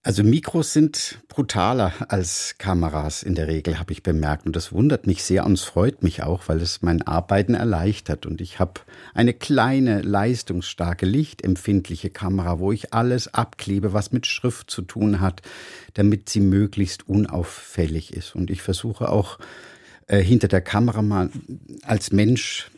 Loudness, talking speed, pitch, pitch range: -22 LUFS, 160 wpm, 100 Hz, 90-115 Hz